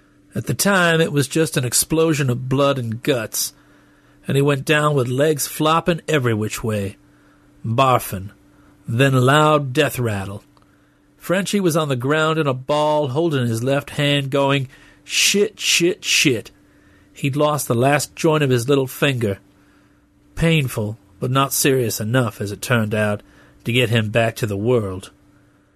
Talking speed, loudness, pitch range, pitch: 160 wpm, -19 LUFS, 115-150 Hz, 135 Hz